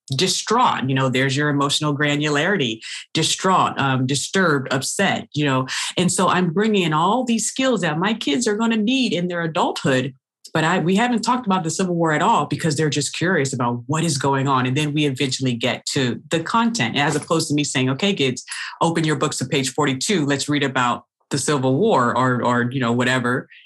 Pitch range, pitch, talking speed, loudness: 130-180 Hz, 150 Hz, 210 wpm, -20 LUFS